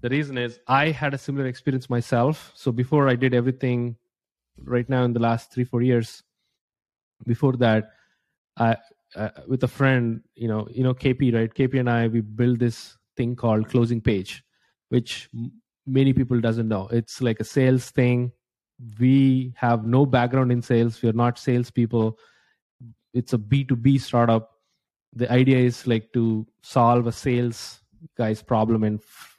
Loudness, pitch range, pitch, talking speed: -23 LUFS, 115-130 Hz, 120 Hz, 165 wpm